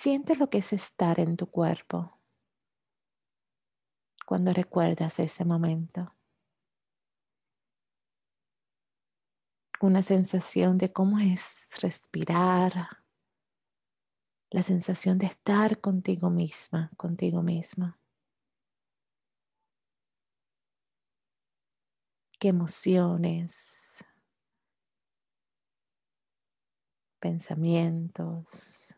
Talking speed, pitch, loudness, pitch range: 60 wpm, 180 Hz, -28 LUFS, 170-190 Hz